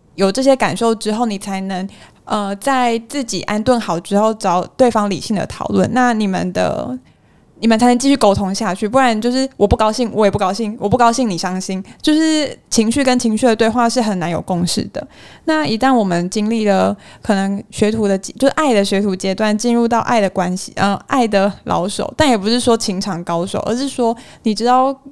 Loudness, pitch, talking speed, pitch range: -16 LUFS, 215 Hz, 305 characters per minute, 195-245 Hz